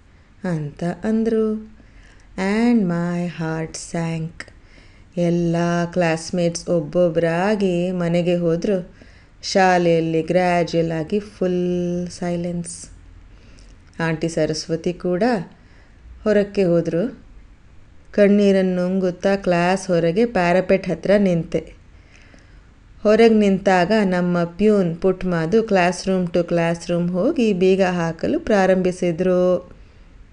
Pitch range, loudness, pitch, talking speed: 165-190 Hz, -19 LUFS, 175 Hz, 85 wpm